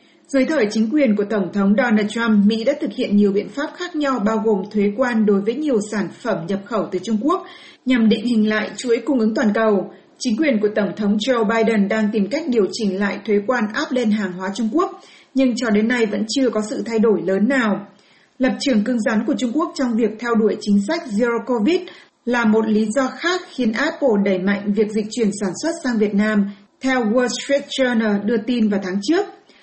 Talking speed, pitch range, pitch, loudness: 235 wpm, 210-260 Hz, 225 Hz, -19 LUFS